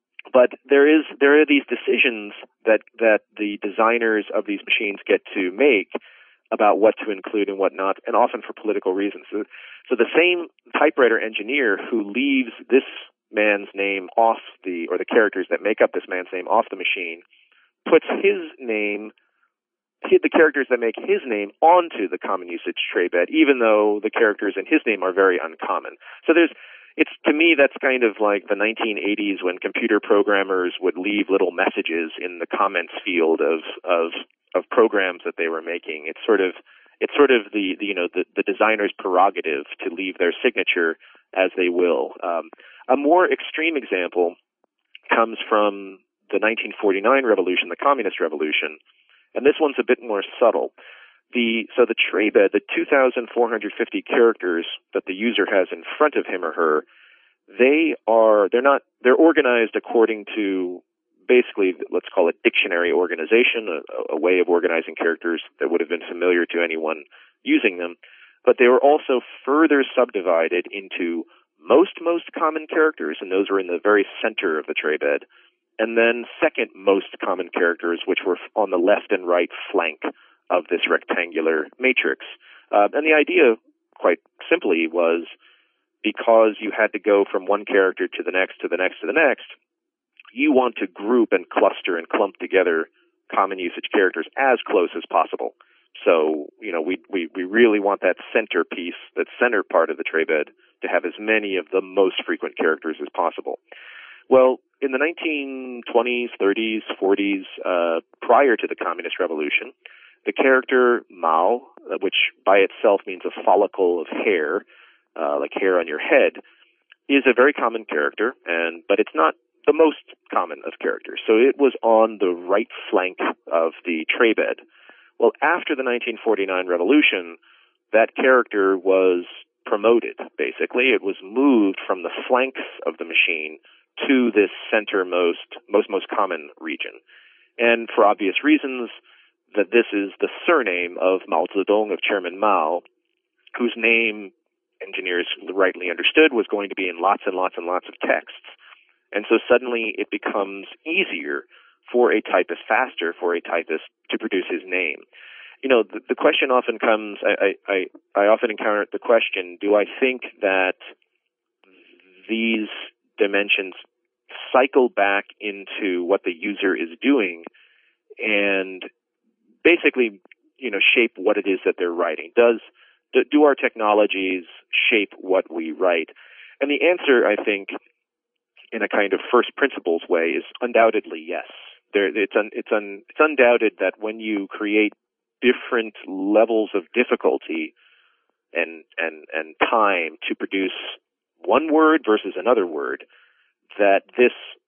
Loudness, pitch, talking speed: -20 LUFS, 125 Hz, 165 wpm